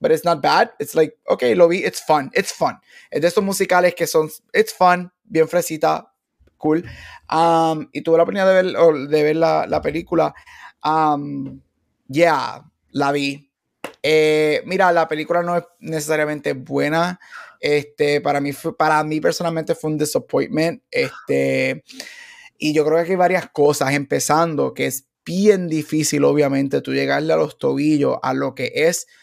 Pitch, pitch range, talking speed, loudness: 160 Hz, 150-180 Hz, 170 wpm, -19 LUFS